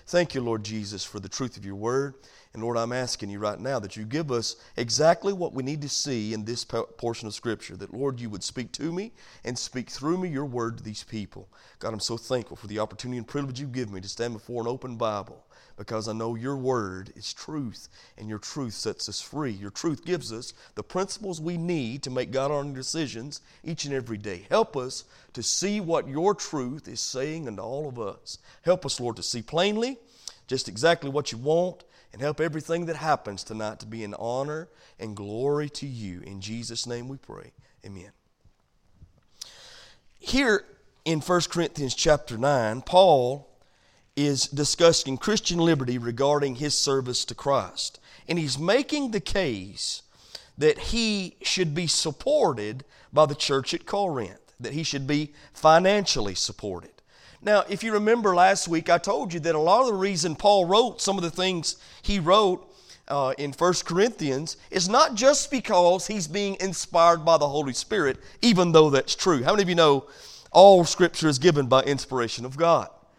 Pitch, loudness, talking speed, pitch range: 140 Hz, -25 LUFS, 190 wpm, 120-170 Hz